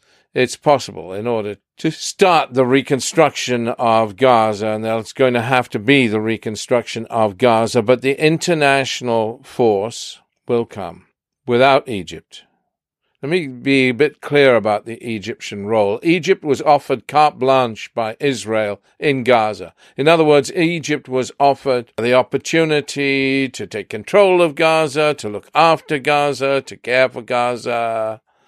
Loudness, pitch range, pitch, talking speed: -16 LUFS, 115-145 Hz, 130 Hz, 145 wpm